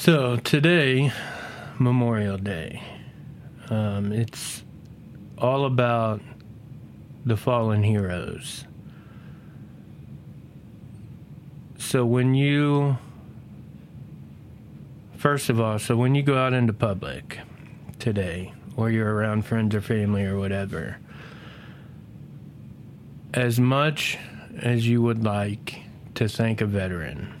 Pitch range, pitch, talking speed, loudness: 105-135 Hz, 120 Hz, 95 wpm, -24 LUFS